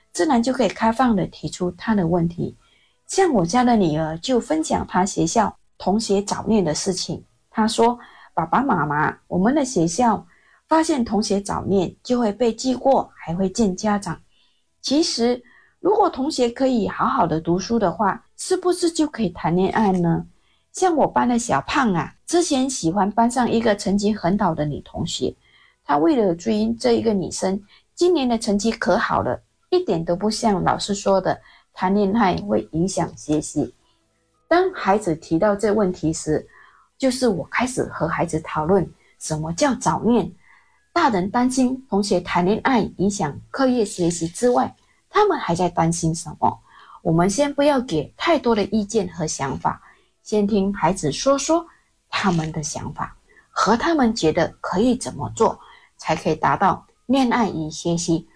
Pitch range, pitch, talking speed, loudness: 175-245 Hz, 210 Hz, 245 characters per minute, -21 LUFS